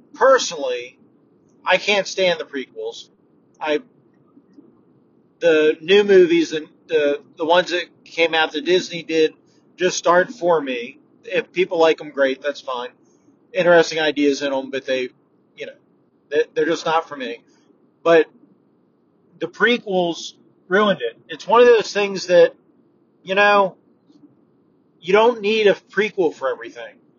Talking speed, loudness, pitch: 140 wpm, -18 LUFS, 190 Hz